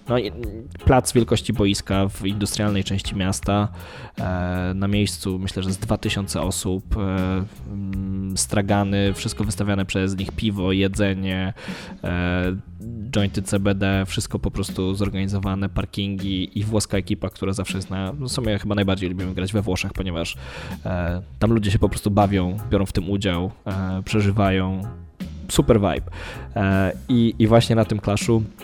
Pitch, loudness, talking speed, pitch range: 100 Hz, -23 LUFS, 135 wpm, 95-105 Hz